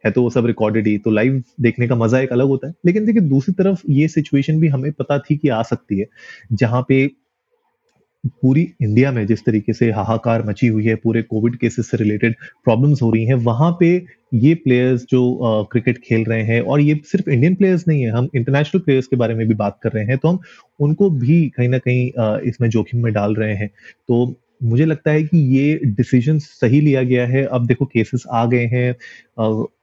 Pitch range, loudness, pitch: 115-145 Hz, -17 LUFS, 125 Hz